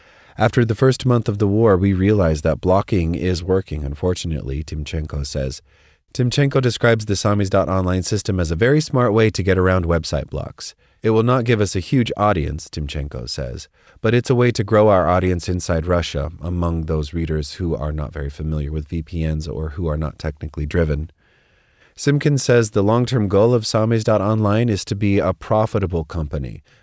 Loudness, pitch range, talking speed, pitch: -19 LUFS, 80-110 Hz, 180 wpm, 90 Hz